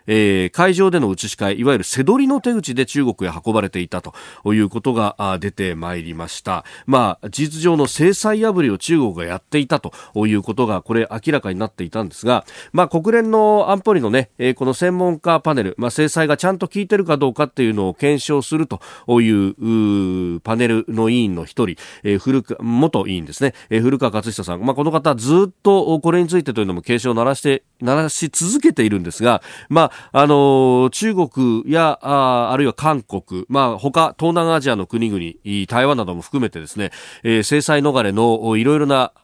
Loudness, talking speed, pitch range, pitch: -17 LUFS, 360 characters per minute, 105-155 Hz, 125 Hz